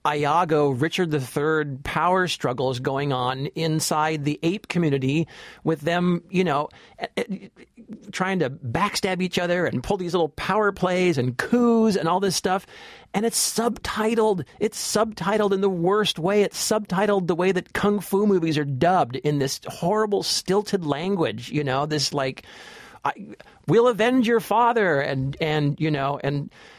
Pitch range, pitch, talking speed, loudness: 150-205 Hz, 175 Hz, 155 wpm, -23 LUFS